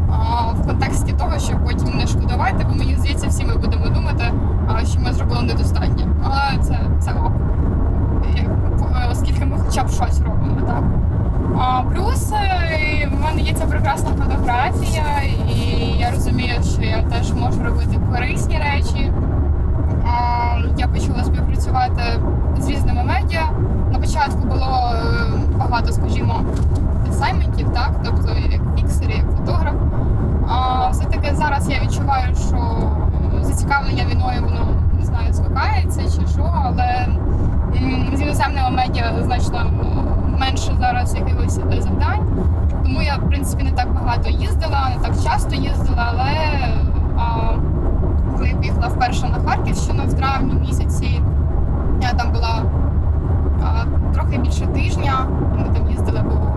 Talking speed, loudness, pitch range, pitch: 130 wpm, -19 LUFS, 80-95 Hz, 90 Hz